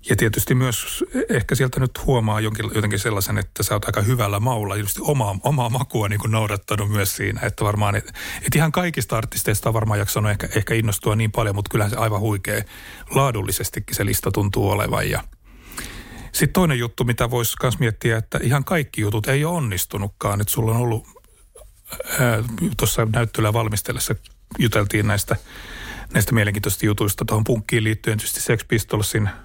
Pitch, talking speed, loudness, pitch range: 110 Hz, 165 wpm, -21 LUFS, 105-120 Hz